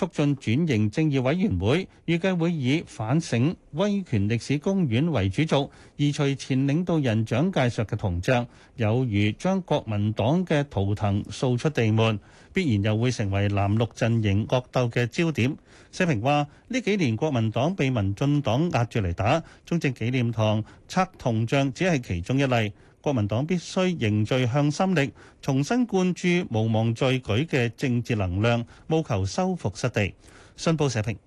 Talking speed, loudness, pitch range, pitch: 245 characters per minute, -25 LUFS, 110-155 Hz, 130 Hz